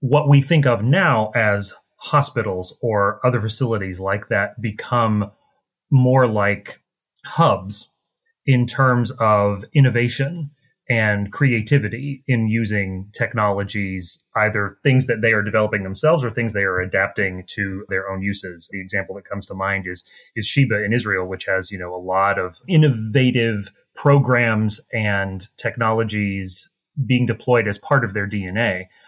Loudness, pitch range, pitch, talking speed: -19 LUFS, 100-125 Hz, 110 Hz, 145 wpm